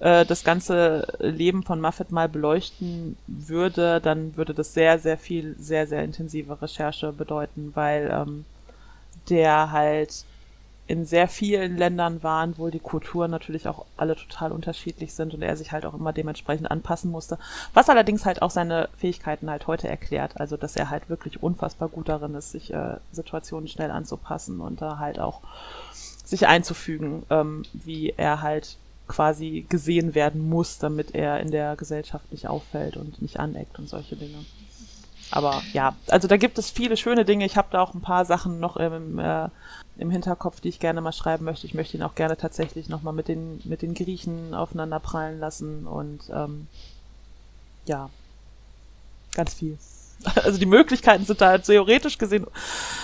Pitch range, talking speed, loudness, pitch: 150-175 Hz, 170 wpm, -24 LUFS, 160 Hz